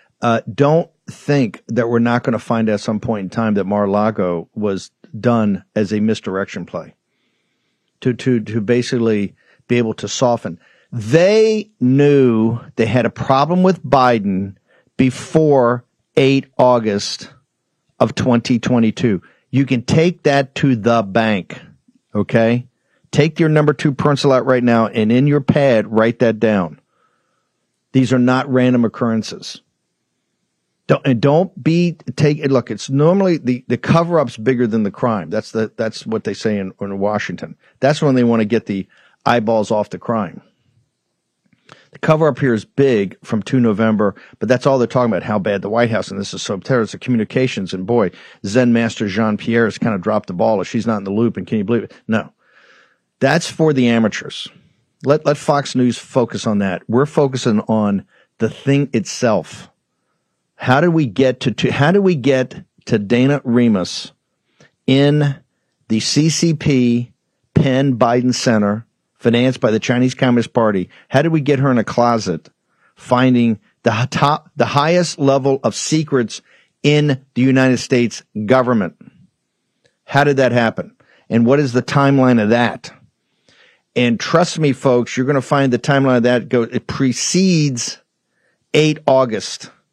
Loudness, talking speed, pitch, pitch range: -16 LUFS, 165 wpm, 125 Hz, 115-140 Hz